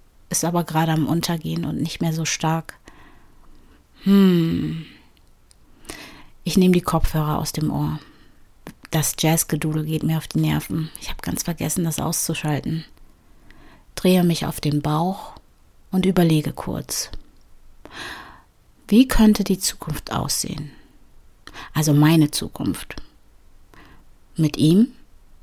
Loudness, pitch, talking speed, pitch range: -21 LUFS, 160 Hz, 115 wpm, 150-175 Hz